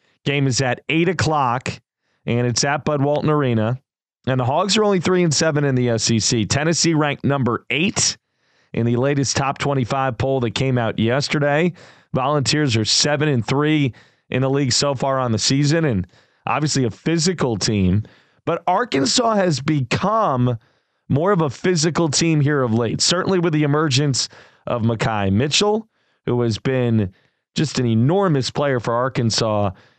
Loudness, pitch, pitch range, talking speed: -19 LUFS, 140 Hz, 120-155 Hz, 165 wpm